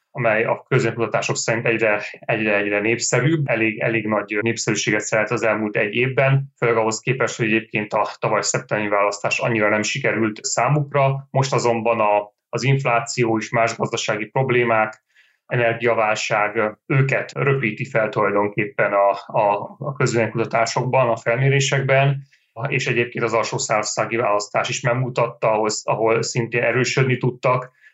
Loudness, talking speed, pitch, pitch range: -20 LUFS, 135 wpm, 115 Hz, 110-130 Hz